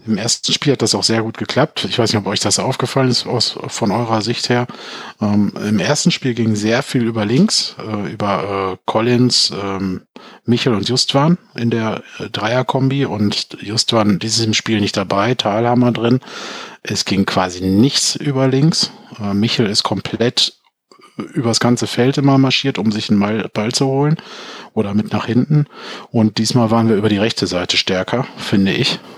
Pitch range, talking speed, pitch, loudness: 105-130 Hz, 170 wpm, 115 Hz, -16 LUFS